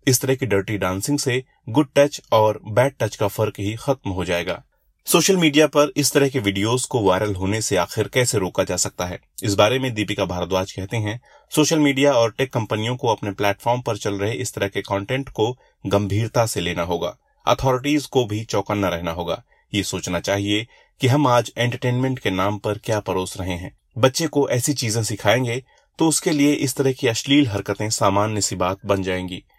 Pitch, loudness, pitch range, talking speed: 110 Hz, -21 LUFS, 100-130 Hz, 200 wpm